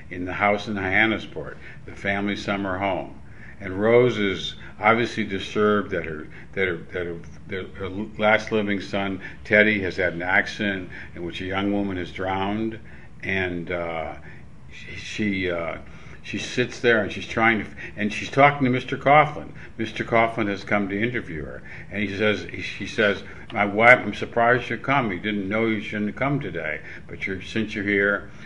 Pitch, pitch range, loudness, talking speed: 100 Hz, 95-110 Hz, -23 LUFS, 185 wpm